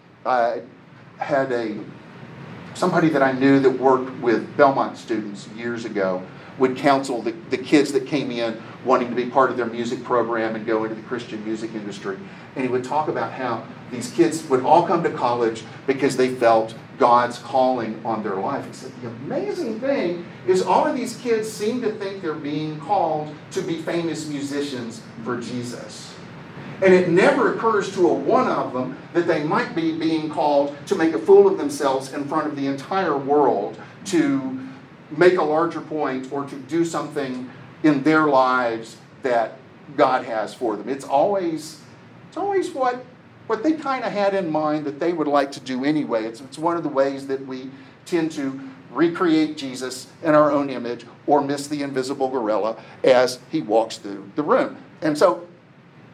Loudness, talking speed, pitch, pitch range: -22 LUFS, 185 wpm, 140 Hz, 125-170 Hz